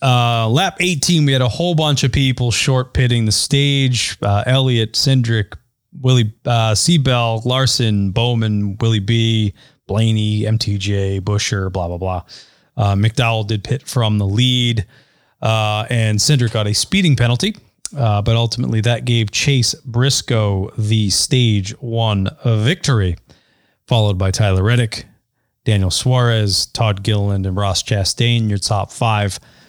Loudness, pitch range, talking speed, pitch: -16 LUFS, 105-125 Hz, 140 wpm, 115 Hz